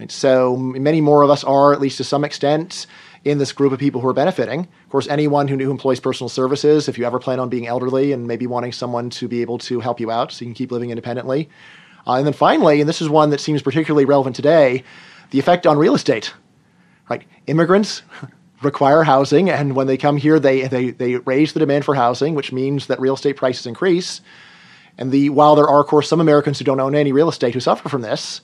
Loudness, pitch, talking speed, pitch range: -17 LUFS, 140 Hz, 235 wpm, 130-150 Hz